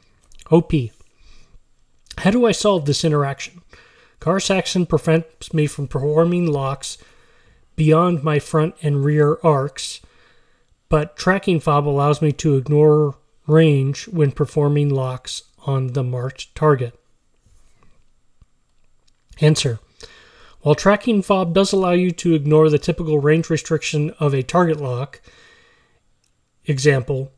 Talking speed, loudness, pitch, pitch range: 115 wpm, -18 LUFS, 150 Hz, 140-165 Hz